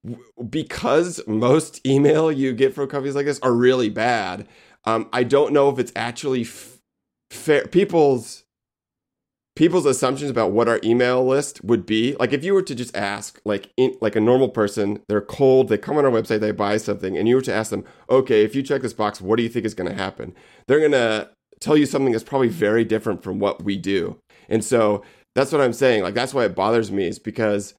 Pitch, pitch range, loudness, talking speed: 120 Hz, 110-135 Hz, -20 LUFS, 220 wpm